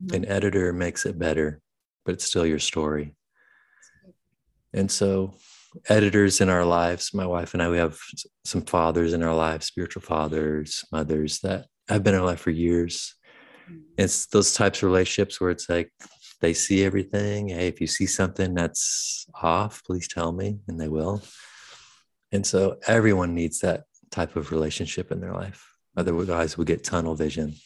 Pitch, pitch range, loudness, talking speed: 85 Hz, 80-95 Hz, -25 LUFS, 170 wpm